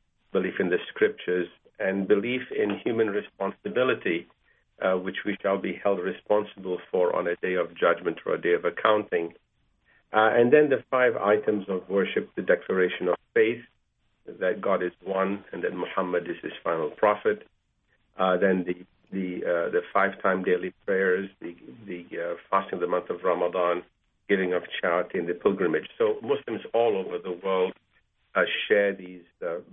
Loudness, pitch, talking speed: -26 LUFS, 105 Hz, 170 wpm